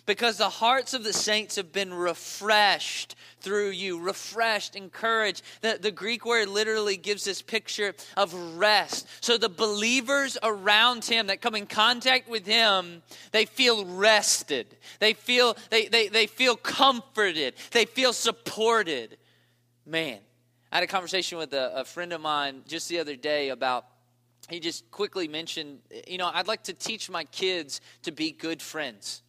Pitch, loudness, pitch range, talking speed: 200 Hz, -25 LUFS, 170-225 Hz, 160 wpm